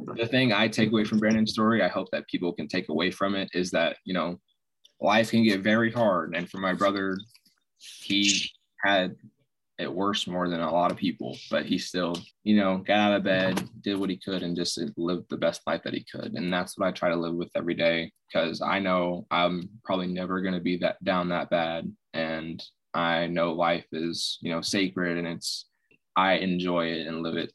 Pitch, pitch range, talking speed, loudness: 90 Hz, 85-100 Hz, 220 wpm, -27 LUFS